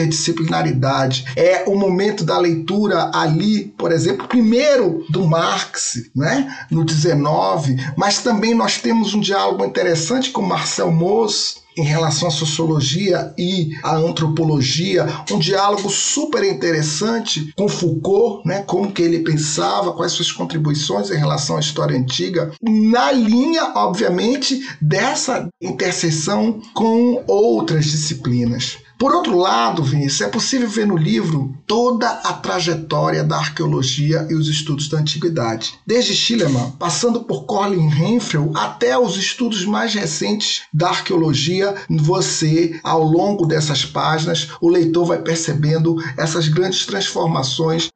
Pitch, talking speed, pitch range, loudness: 170 Hz, 130 wpm, 155-200 Hz, -17 LUFS